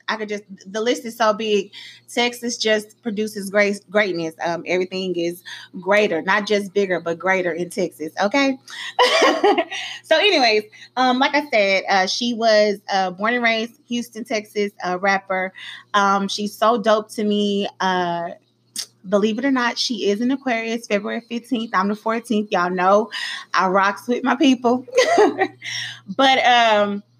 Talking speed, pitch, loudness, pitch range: 155 wpm, 215 Hz, -19 LUFS, 195-240 Hz